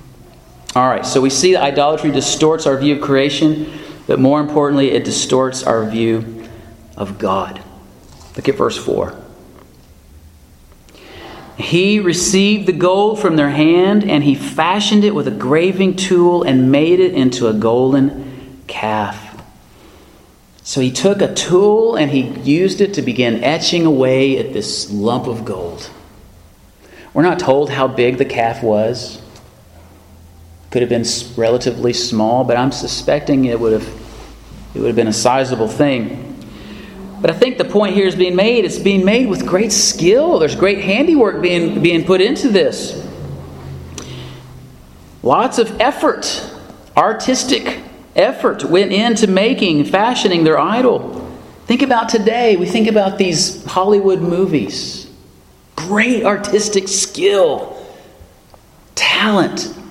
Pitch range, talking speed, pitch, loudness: 115-190 Hz, 140 wpm, 145 Hz, -14 LUFS